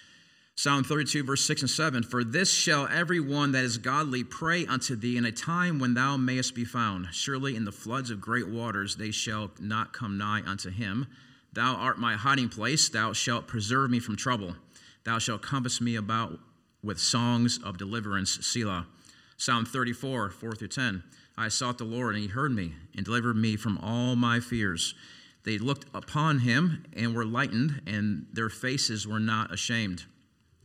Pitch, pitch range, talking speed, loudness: 120 Hz, 110-130 Hz, 180 wpm, -29 LUFS